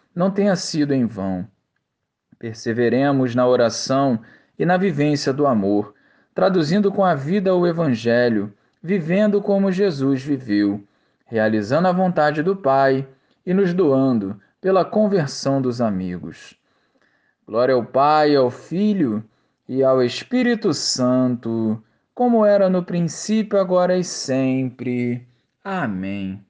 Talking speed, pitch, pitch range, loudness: 120 wpm, 135 Hz, 120-185 Hz, -19 LUFS